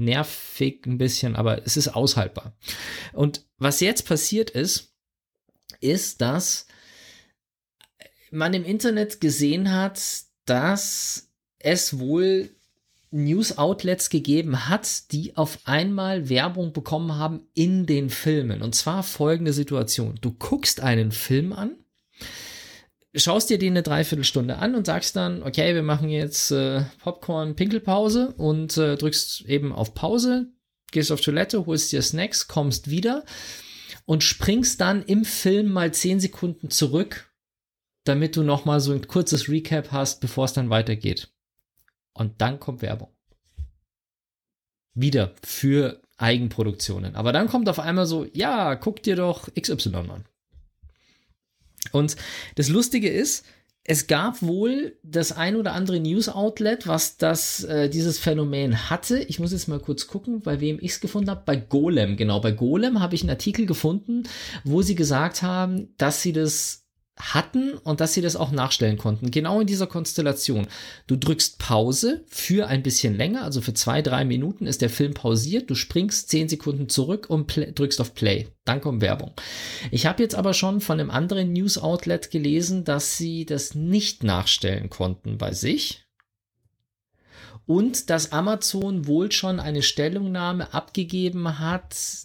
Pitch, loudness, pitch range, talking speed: 155 Hz, -23 LUFS, 130-185 Hz, 150 wpm